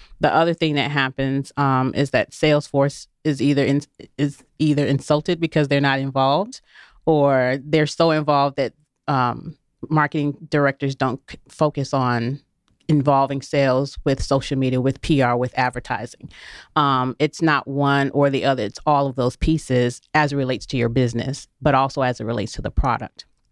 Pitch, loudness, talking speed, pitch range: 140 Hz, -20 LUFS, 170 wpm, 130-150 Hz